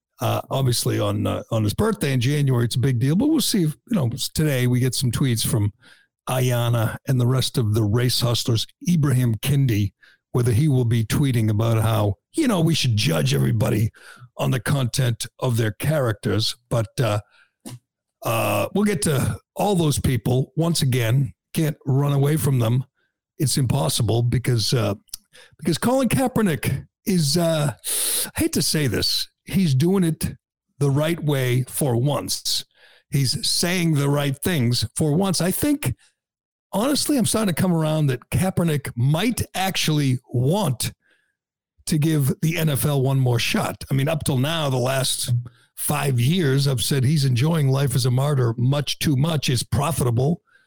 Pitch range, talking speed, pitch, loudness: 120-155 Hz, 165 wpm, 135 Hz, -21 LUFS